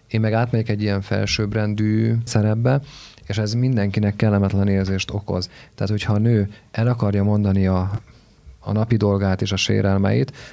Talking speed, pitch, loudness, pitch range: 155 wpm, 105 Hz, -20 LUFS, 100-115 Hz